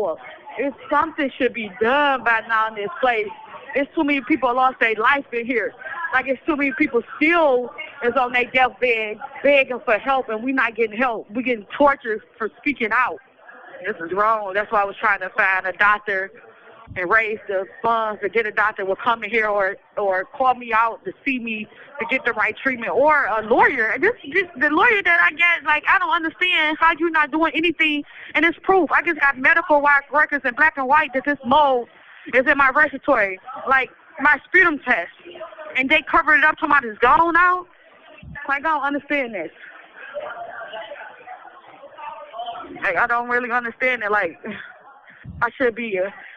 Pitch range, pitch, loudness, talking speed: 230-305 Hz, 265 Hz, -19 LUFS, 190 wpm